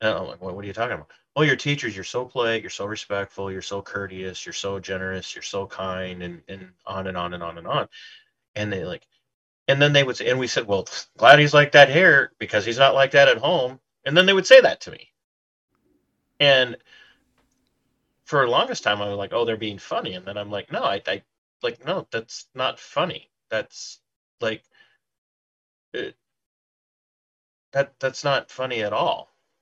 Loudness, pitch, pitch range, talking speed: -21 LUFS, 110 Hz, 95-135 Hz, 205 wpm